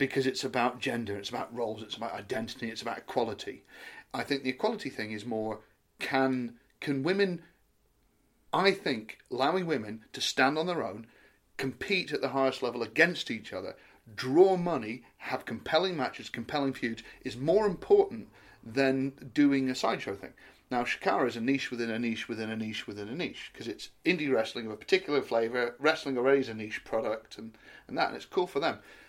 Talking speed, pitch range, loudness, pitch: 190 wpm, 115-140 Hz, -31 LUFS, 130 Hz